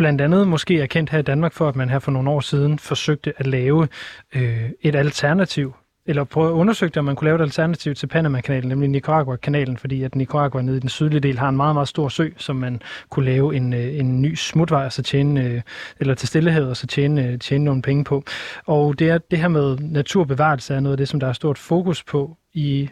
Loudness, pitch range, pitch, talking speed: -20 LUFS, 135-155 Hz, 145 Hz, 235 wpm